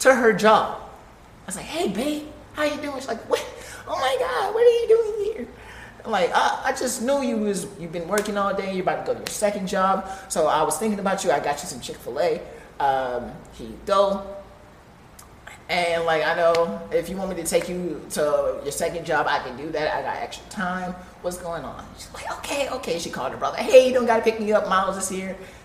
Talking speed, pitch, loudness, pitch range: 240 wpm, 195 Hz, -23 LUFS, 170-250 Hz